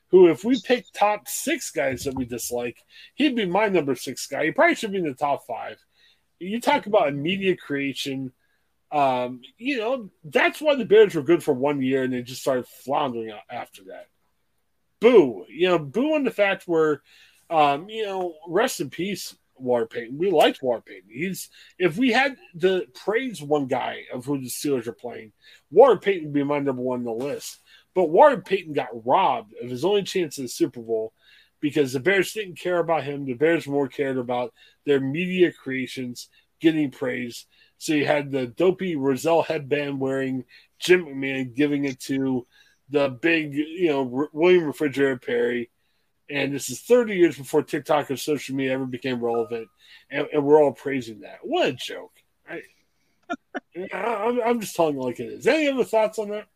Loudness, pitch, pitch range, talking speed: -23 LUFS, 150 Hz, 135-185 Hz, 190 wpm